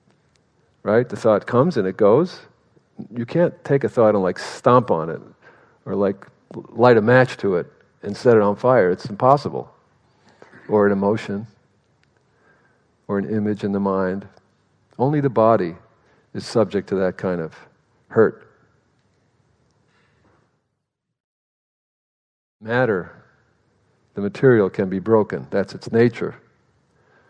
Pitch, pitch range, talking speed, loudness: 105 Hz, 100-120 Hz, 130 wpm, -19 LUFS